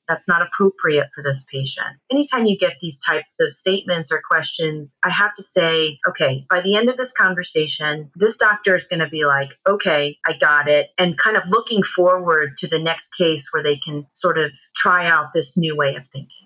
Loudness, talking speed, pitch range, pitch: -18 LUFS, 210 wpm, 150-185 Hz, 165 Hz